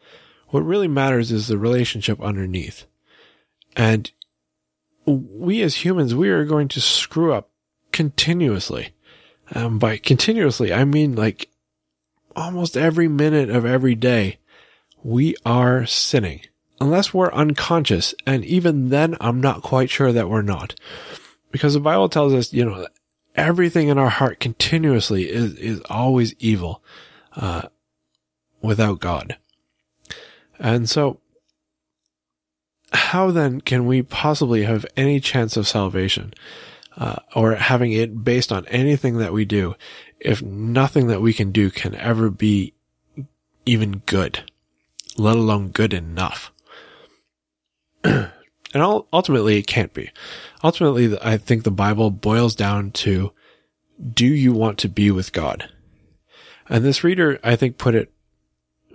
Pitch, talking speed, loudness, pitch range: 115 Hz, 130 wpm, -19 LUFS, 100-140 Hz